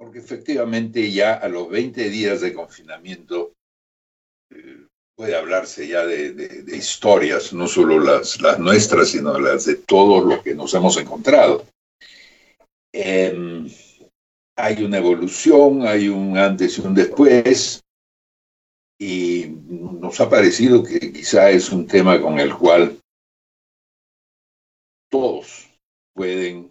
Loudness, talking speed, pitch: -16 LUFS, 125 wpm, 105 Hz